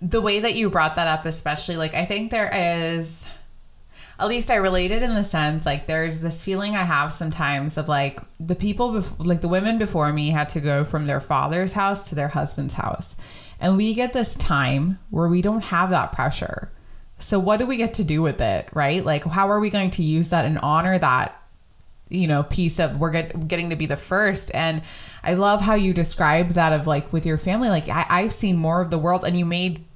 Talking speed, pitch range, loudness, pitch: 230 wpm, 155-195 Hz, -22 LUFS, 170 Hz